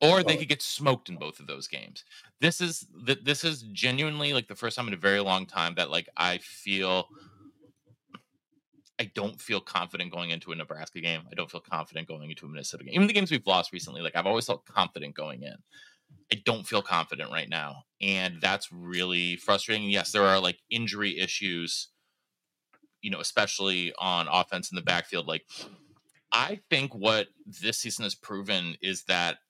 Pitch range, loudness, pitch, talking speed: 90-140 Hz, -28 LUFS, 100 Hz, 190 wpm